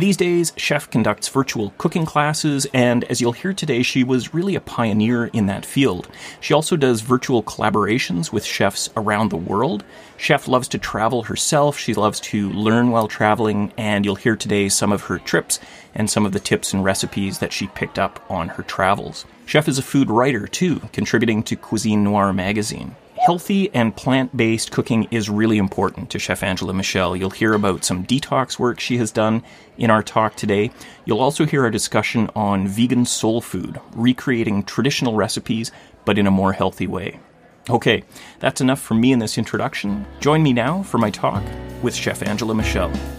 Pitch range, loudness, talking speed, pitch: 100-130 Hz, -19 LUFS, 190 wpm, 115 Hz